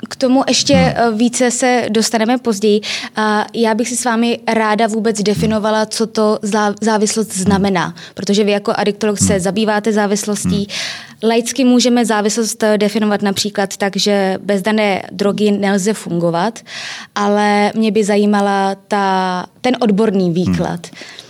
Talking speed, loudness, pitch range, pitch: 130 wpm, -15 LUFS, 200-225 Hz, 210 Hz